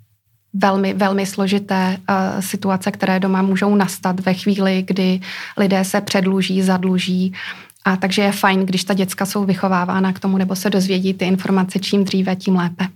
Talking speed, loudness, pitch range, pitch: 165 wpm, -18 LUFS, 185-195 Hz, 190 Hz